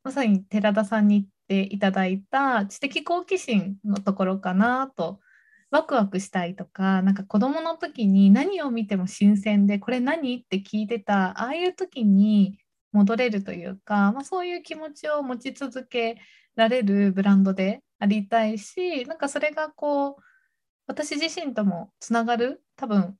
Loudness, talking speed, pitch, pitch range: -24 LUFS, 315 characters per minute, 220 Hz, 200-280 Hz